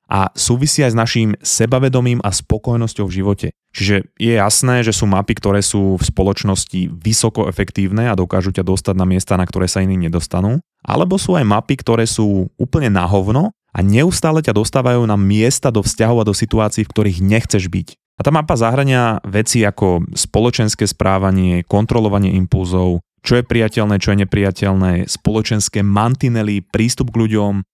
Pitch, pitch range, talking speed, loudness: 105 Hz, 95-115 Hz, 170 wpm, -15 LUFS